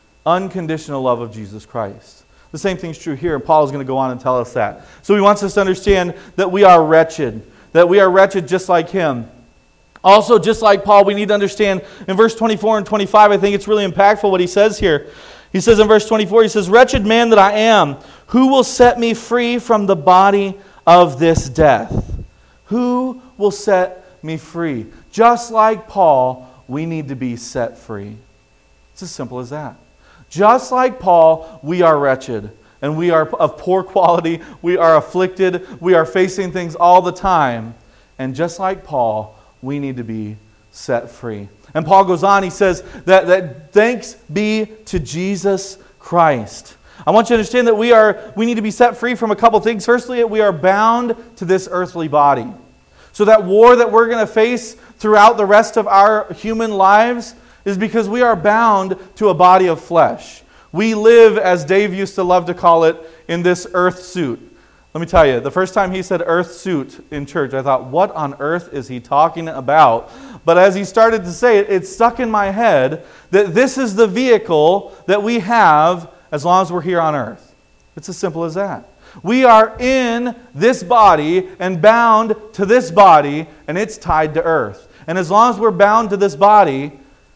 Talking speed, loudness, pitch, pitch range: 200 wpm, -13 LUFS, 190 Hz, 160-215 Hz